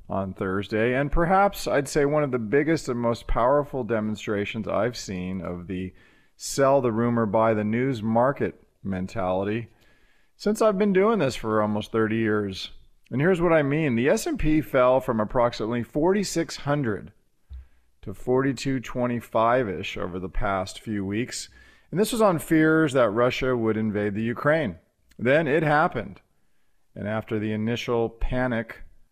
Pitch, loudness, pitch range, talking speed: 115 Hz, -24 LUFS, 105-140 Hz, 150 wpm